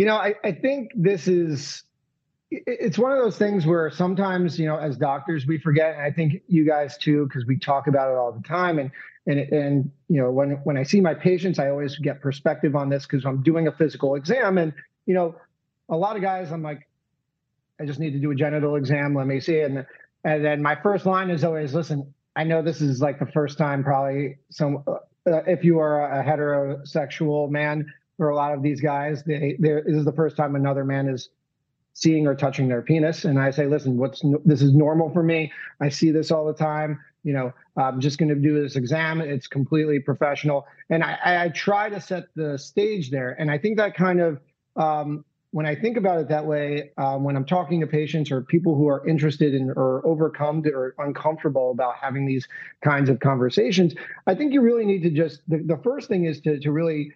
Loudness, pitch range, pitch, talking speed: -23 LUFS, 140-165 Hz, 150 Hz, 220 wpm